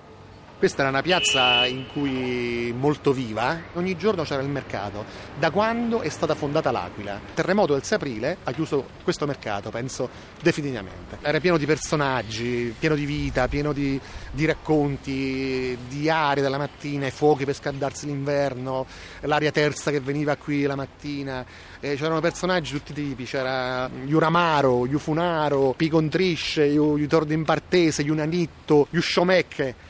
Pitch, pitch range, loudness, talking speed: 145 Hz, 130-155 Hz, -24 LUFS, 145 wpm